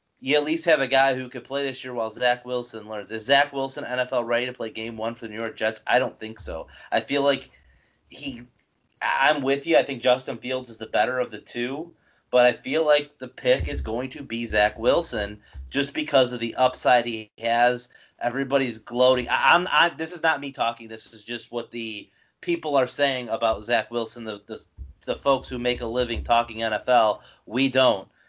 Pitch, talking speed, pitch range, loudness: 125 Hz, 220 wpm, 115-135 Hz, -24 LUFS